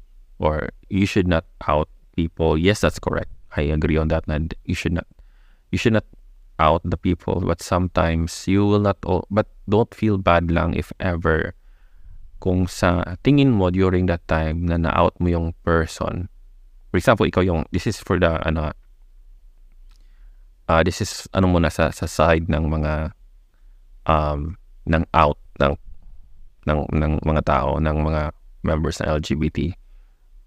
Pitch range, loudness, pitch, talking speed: 80-90 Hz, -21 LUFS, 85 Hz, 160 wpm